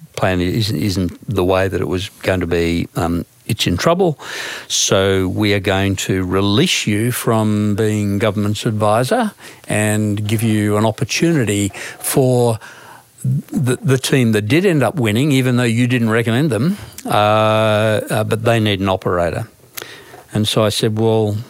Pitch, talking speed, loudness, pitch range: 110 Hz, 160 wpm, -16 LUFS, 100-125 Hz